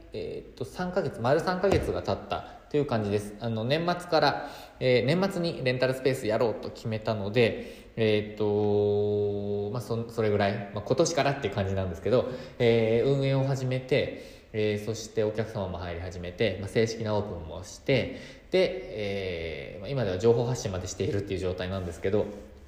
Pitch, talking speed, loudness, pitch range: 110 Hz, 370 characters per minute, -28 LUFS, 100-130 Hz